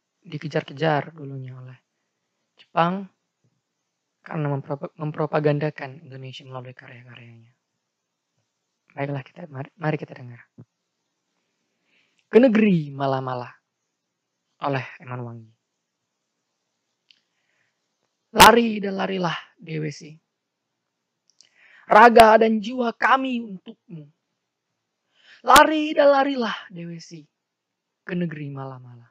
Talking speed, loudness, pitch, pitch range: 75 wpm, -19 LUFS, 155 Hz, 135-200 Hz